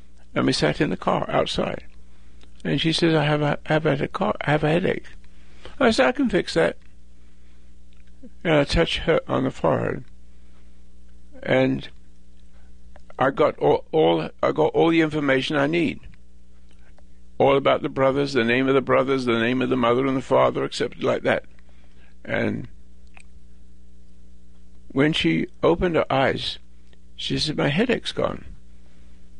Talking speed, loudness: 155 wpm, -22 LUFS